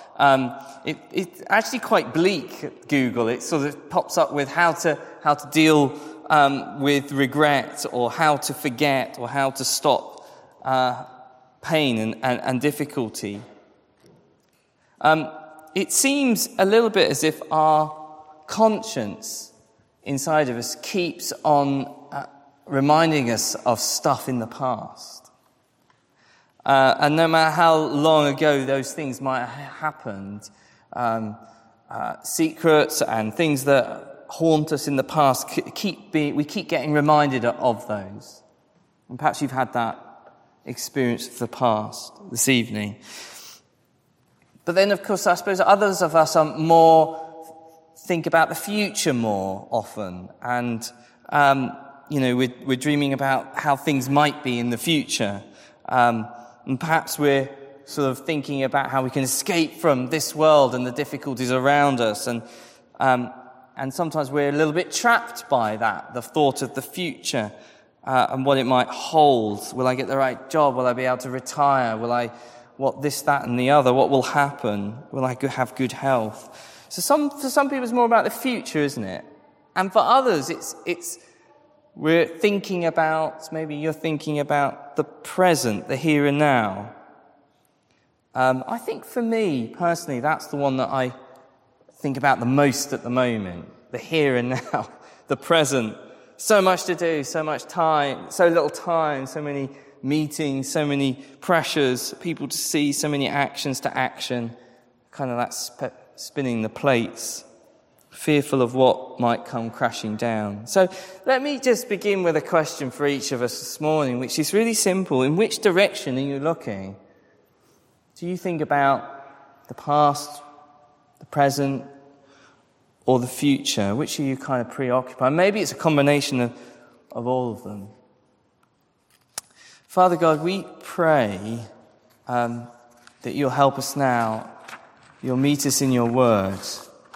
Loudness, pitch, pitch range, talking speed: -22 LUFS, 140 Hz, 125-155 Hz, 155 wpm